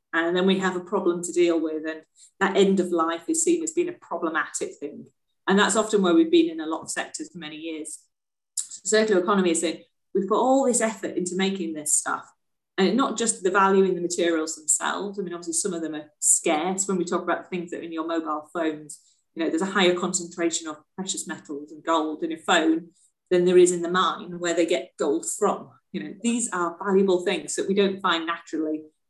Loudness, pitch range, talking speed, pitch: -24 LUFS, 165-200 Hz, 235 wpm, 180 Hz